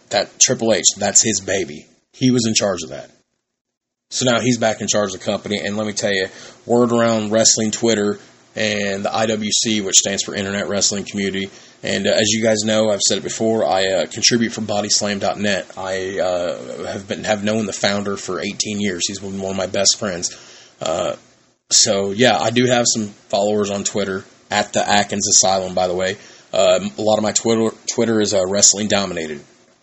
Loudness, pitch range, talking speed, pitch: -17 LUFS, 100-110 Hz, 200 wpm, 105 Hz